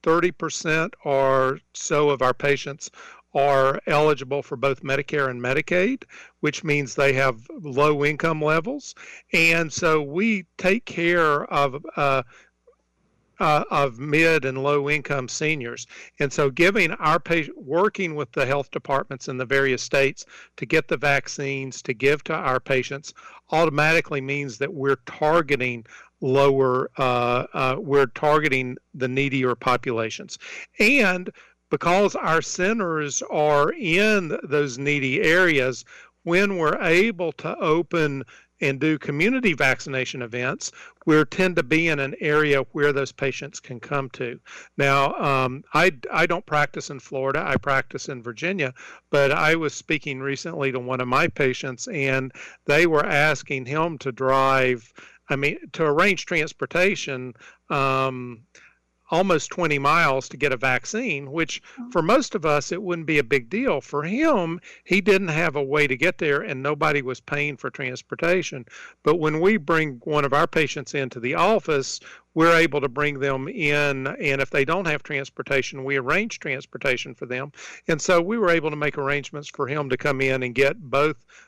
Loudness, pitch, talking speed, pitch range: -22 LUFS, 145 Hz, 160 wpm, 135-165 Hz